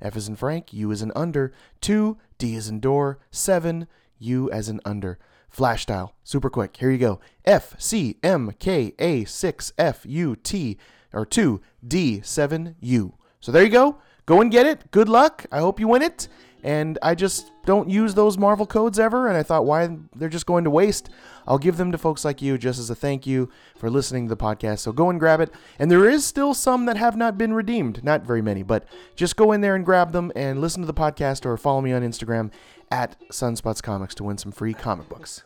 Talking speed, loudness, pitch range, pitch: 225 wpm, -22 LUFS, 115-185 Hz, 145 Hz